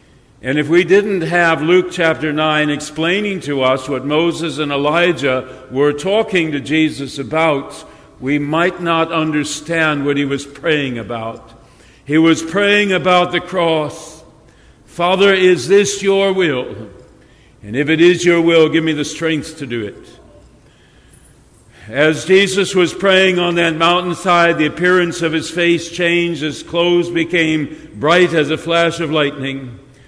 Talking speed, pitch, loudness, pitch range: 150 wpm, 160 Hz, -15 LUFS, 145-175 Hz